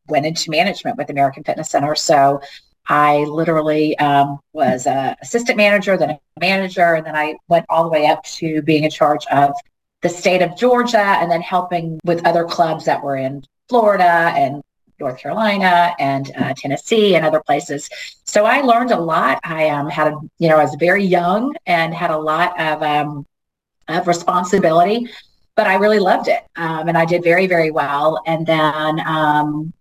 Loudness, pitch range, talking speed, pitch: -16 LUFS, 150-180 Hz, 185 wpm, 165 Hz